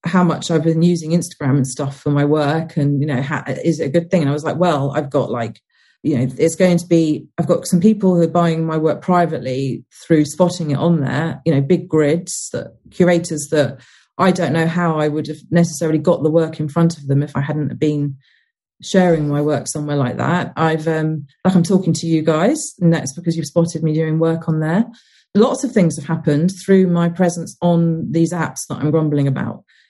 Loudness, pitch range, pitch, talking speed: -17 LUFS, 150-175 Hz, 160 Hz, 230 wpm